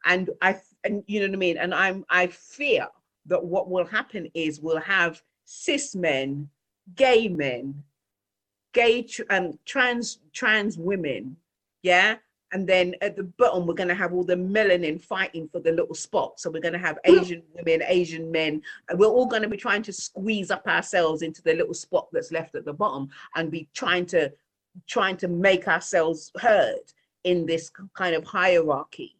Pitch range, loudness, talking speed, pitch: 165-205 Hz, -24 LUFS, 185 wpm, 180 Hz